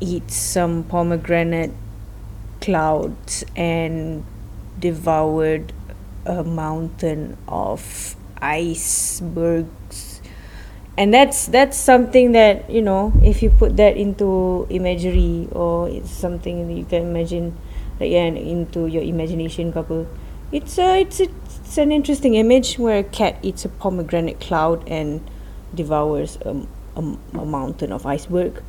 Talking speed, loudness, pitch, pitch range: 125 wpm, -19 LUFS, 170 Hz, 155-190 Hz